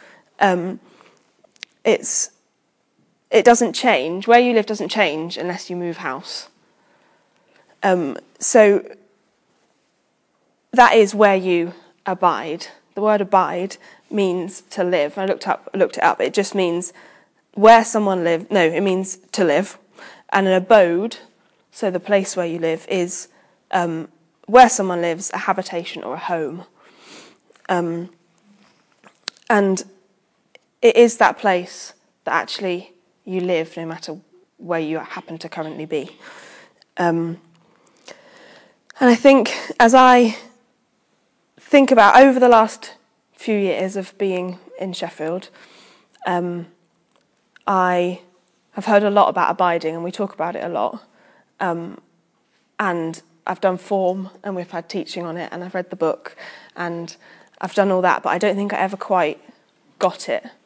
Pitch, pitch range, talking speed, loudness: 185 Hz, 170-205 Hz, 140 wpm, -18 LUFS